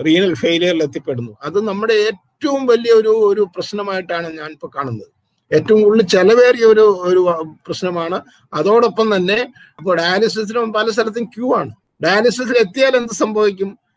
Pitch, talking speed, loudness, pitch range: 205 Hz, 135 wpm, -15 LUFS, 175-225 Hz